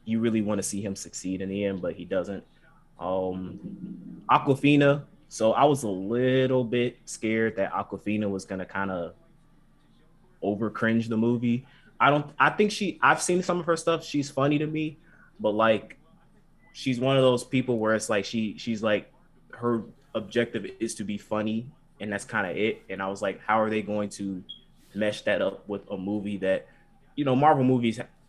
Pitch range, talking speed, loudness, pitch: 105-140 Hz, 195 wpm, -27 LUFS, 115 Hz